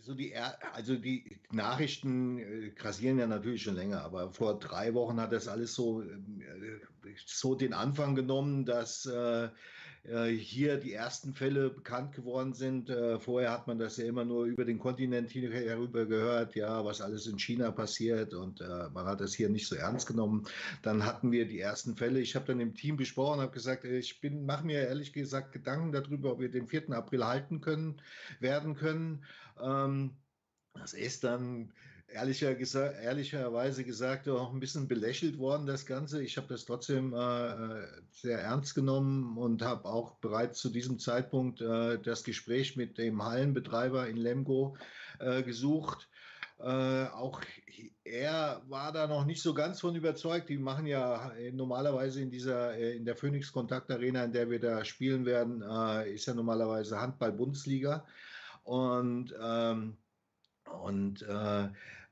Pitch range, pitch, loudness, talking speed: 115-135 Hz, 125 Hz, -35 LUFS, 160 wpm